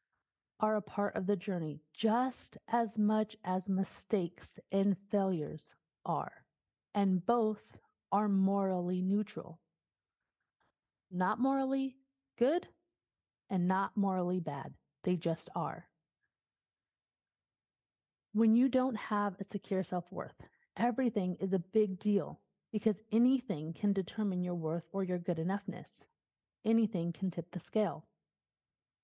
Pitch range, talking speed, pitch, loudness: 180-215 Hz, 120 wpm, 195 Hz, -34 LUFS